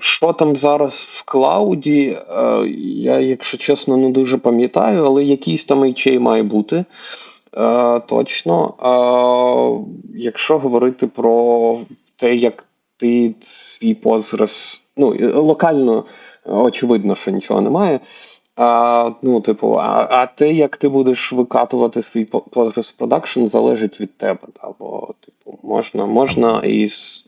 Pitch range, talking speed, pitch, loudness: 115-135 Hz, 120 wpm, 125 Hz, -15 LUFS